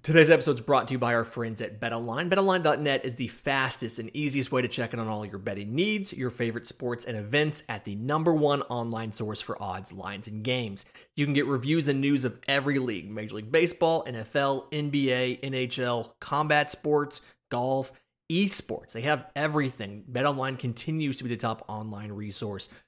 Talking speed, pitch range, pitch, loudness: 190 wpm, 115-145 Hz, 130 Hz, -28 LUFS